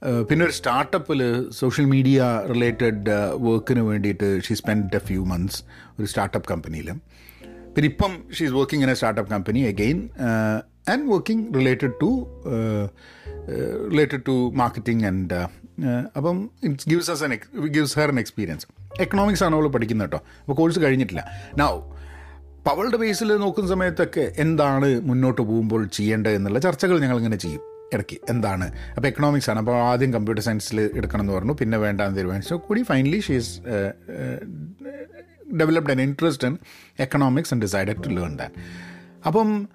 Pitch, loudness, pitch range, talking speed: 120 Hz, -23 LUFS, 100-150 Hz, 135 wpm